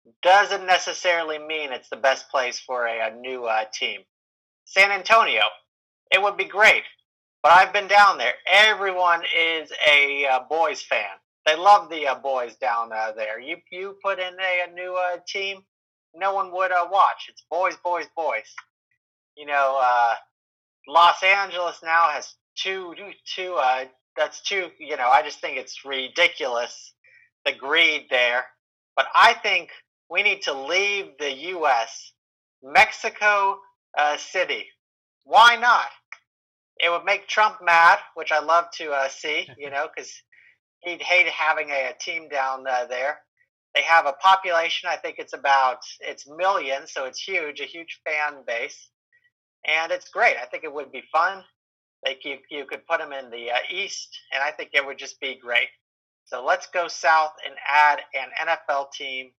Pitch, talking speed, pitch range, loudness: 165 Hz, 170 wpm, 135-195 Hz, -21 LUFS